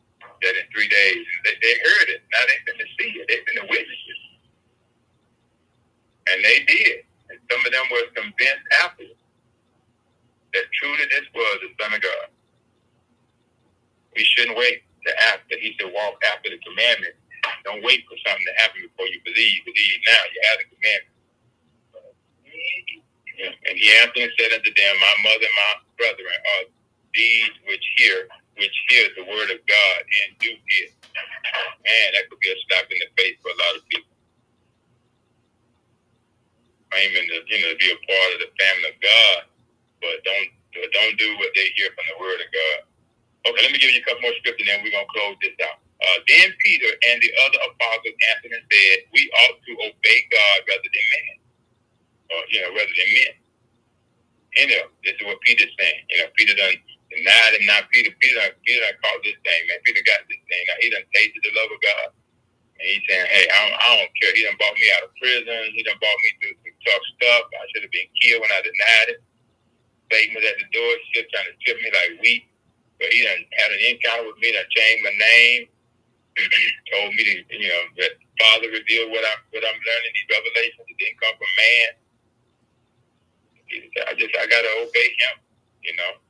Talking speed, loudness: 205 wpm, -17 LUFS